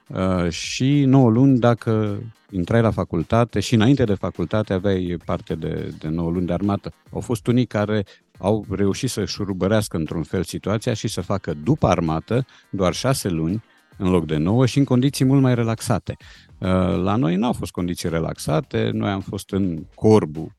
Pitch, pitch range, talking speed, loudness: 100 Hz, 90-120 Hz, 180 wpm, -21 LUFS